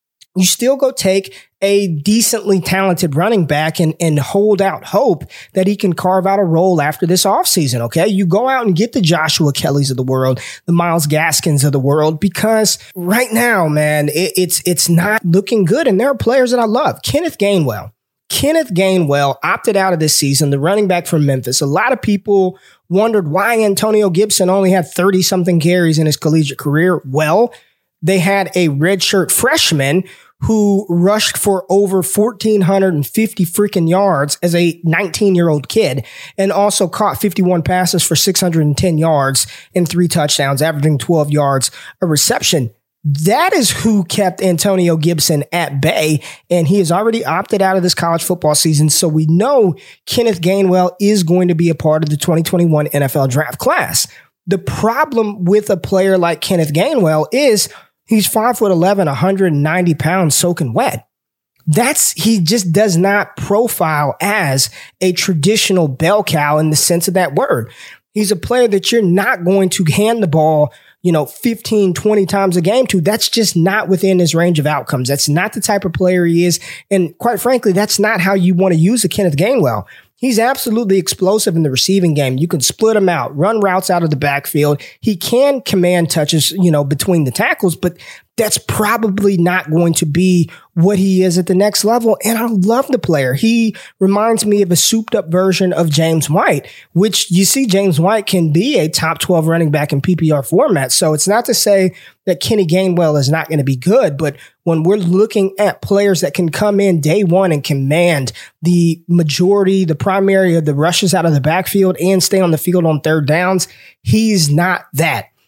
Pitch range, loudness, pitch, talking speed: 160-200 Hz, -13 LUFS, 180 Hz, 190 wpm